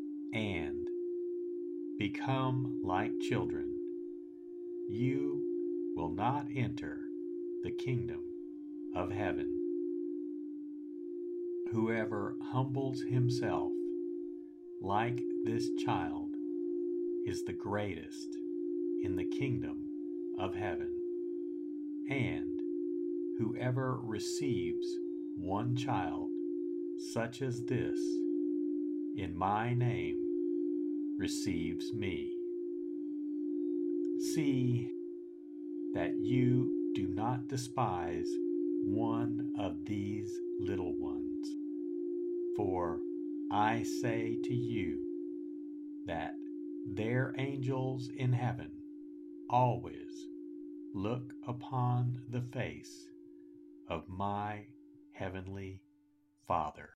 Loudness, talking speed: -37 LUFS, 75 wpm